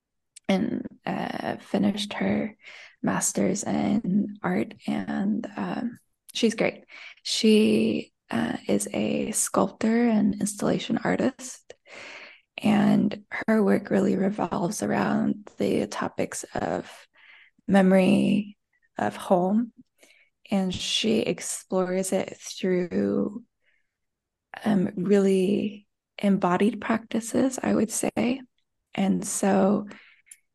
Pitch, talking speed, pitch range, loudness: 210 Hz, 90 wpm, 195-230 Hz, -25 LUFS